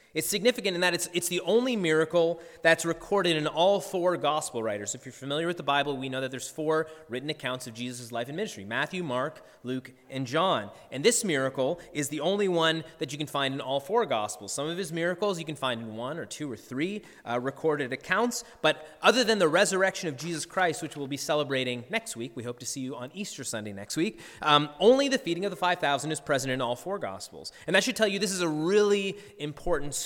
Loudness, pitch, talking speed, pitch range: -28 LUFS, 155 Hz, 235 wpm, 135-185 Hz